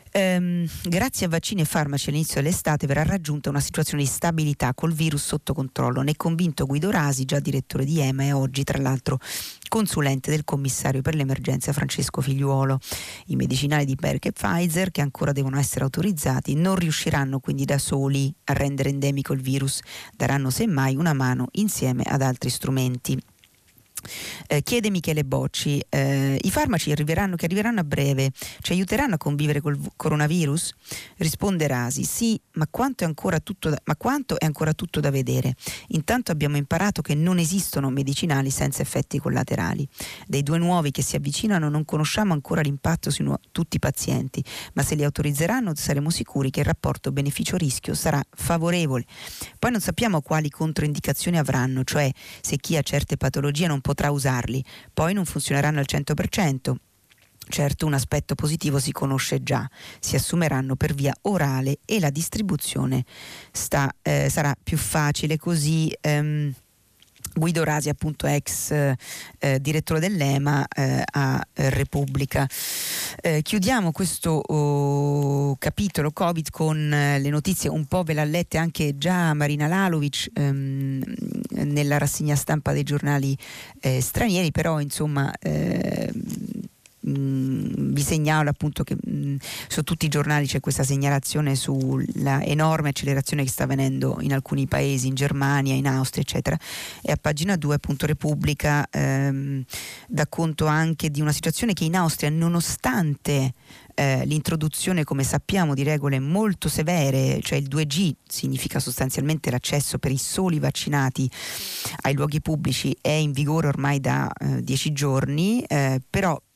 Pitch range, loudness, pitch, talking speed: 135-160 Hz, -24 LUFS, 145 Hz, 150 wpm